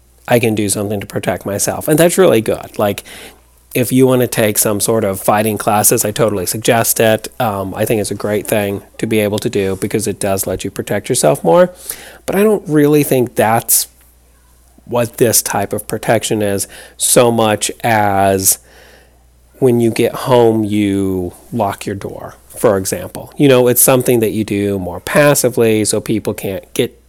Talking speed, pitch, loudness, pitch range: 185 wpm, 110 Hz, -14 LUFS, 100-125 Hz